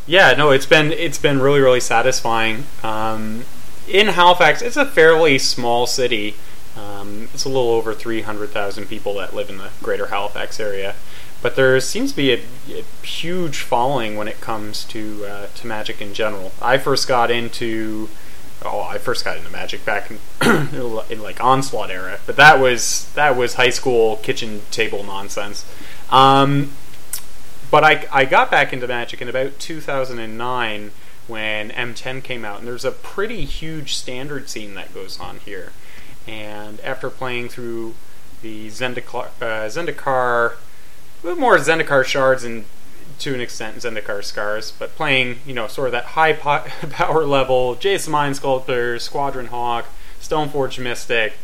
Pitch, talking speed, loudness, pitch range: 125 Hz, 165 wpm, -18 LUFS, 110-140 Hz